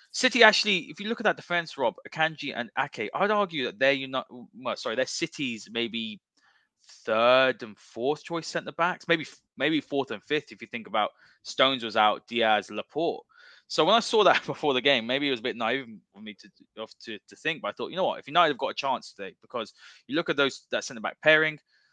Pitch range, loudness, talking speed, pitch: 120-175 Hz, -26 LUFS, 225 wpm, 145 Hz